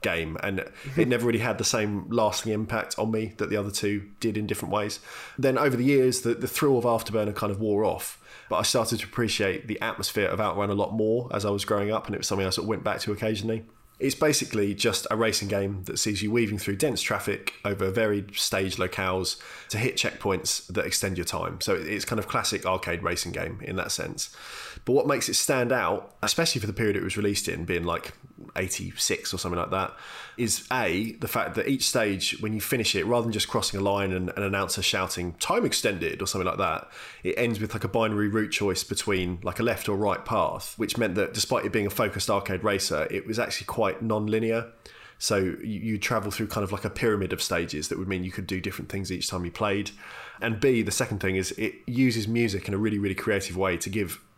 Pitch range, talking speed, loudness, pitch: 95-115 Hz, 235 wpm, -27 LUFS, 105 Hz